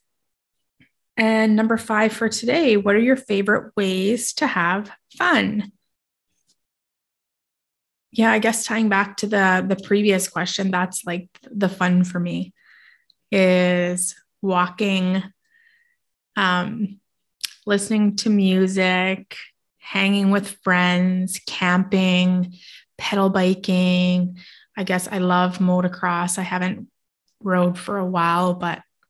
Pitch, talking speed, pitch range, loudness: 190 Hz, 110 wpm, 180-210 Hz, -20 LUFS